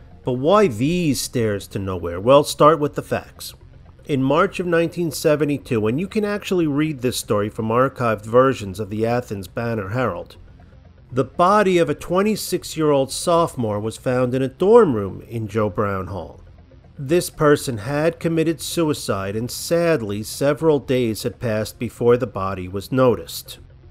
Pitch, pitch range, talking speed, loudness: 125 Hz, 110-155 Hz, 160 wpm, -20 LUFS